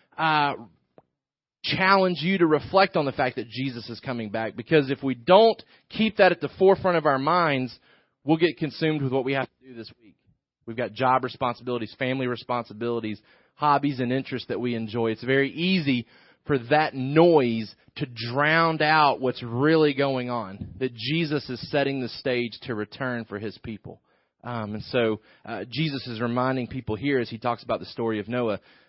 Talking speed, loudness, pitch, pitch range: 185 wpm, -24 LUFS, 130 Hz, 120-150 Hz